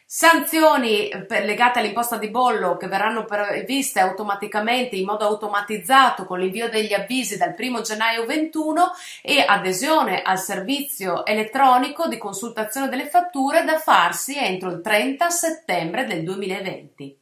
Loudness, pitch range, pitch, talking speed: -20 LUFS, 200-270 Hz, 220 Hz, 130 wpm